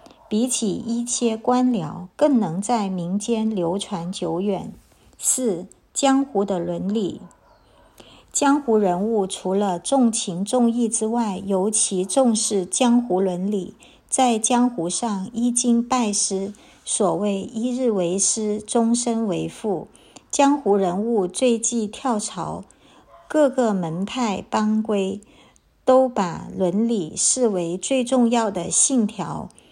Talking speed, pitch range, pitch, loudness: 170 characters per minute, 190-240 Hz, 215 Hz, -21 LUFS